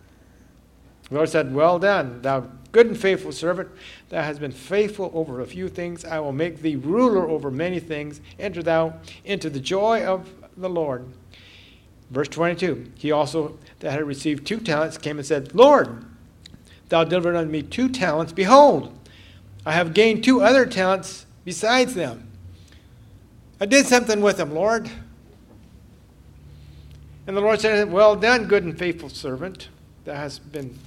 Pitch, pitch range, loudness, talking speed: 160 Hz, 130-190 Hz, -21 LUFS, 155 wpm